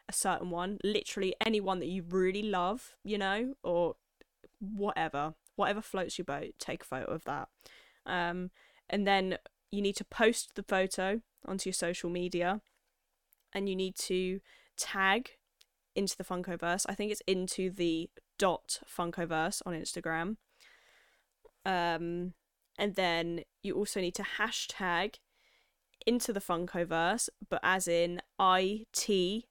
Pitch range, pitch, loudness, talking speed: 175-205 Hz, 190 Hz, -34 LUFS, 140 wpm